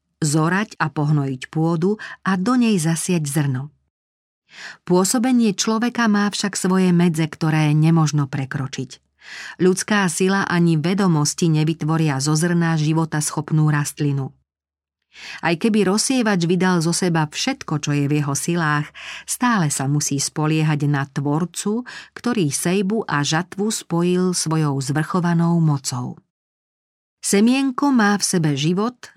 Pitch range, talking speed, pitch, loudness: 150-195 Hz, 120 wpm, 165 Hz, -19 LUFS